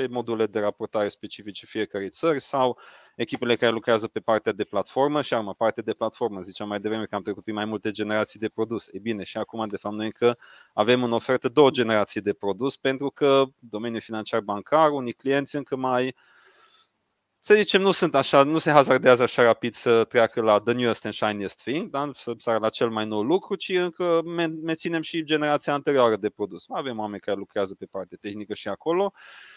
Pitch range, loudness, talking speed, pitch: 105-140 Hz, -24 LUFS, 200 wpm, 120 Hz